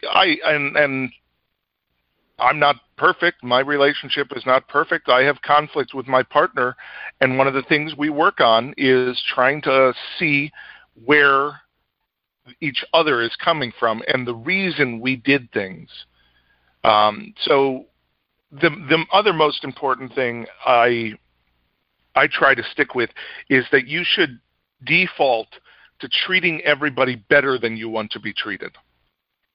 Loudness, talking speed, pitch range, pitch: -18 LUFS, 140 wpm, 120-150 Hz, 135 Hz